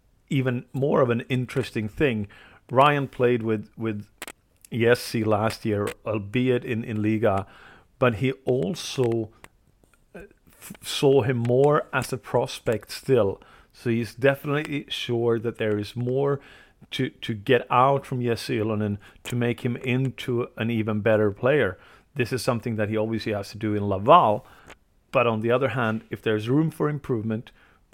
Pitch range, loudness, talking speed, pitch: 110-130 Hz, -24 LUFS, 155 wpm, 120 Hz